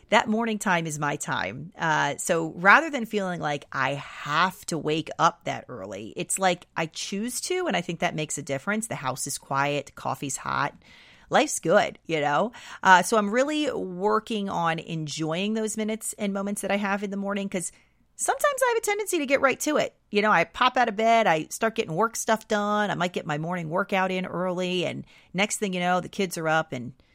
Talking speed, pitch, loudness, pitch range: 220 wpm, 195 Hz, -25 LUFS, 165-220 Hz